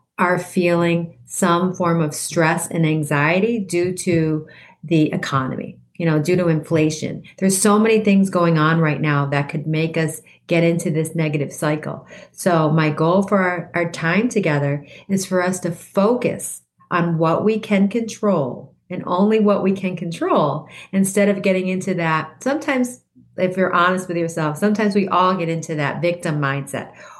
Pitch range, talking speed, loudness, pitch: 155-190 Hz, 170 wpm, -19 LUFS, 175 Hz